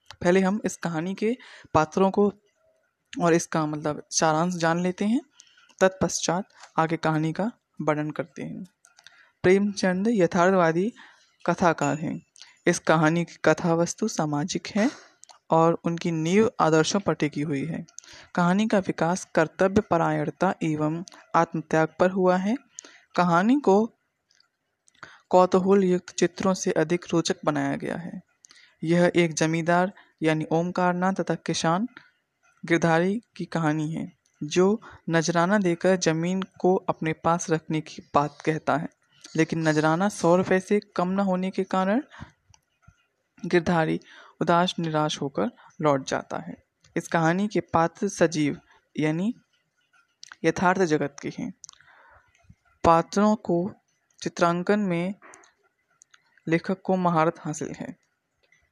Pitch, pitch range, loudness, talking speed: 175 Hz, 160-195 Hz, -25 LUFS, 125 wpm